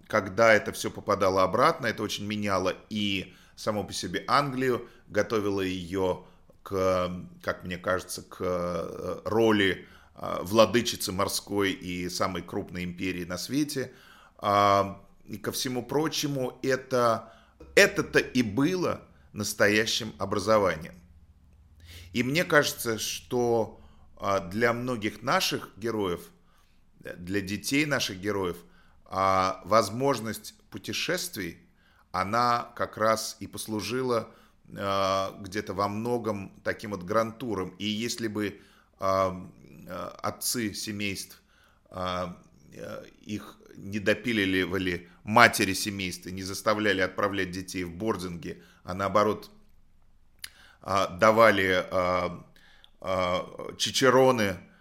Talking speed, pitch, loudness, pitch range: 100 wpm, 100 Hz, -27 LUFS, 95-115 Hz